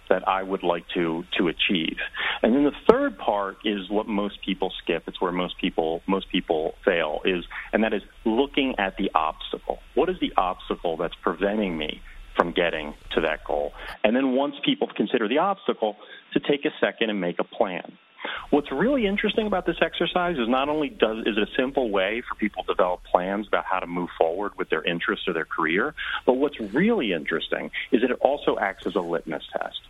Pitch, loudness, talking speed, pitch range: 105 Hz, -25 LUFS, 205 wpm, 90-155 Hz